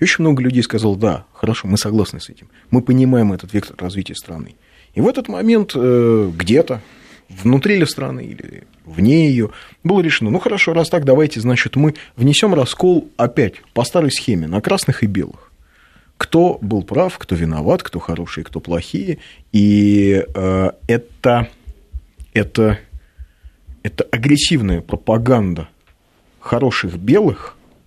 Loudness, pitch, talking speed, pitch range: -16 LUFS, 110 Hz, 140 wpm, 90-140 Hz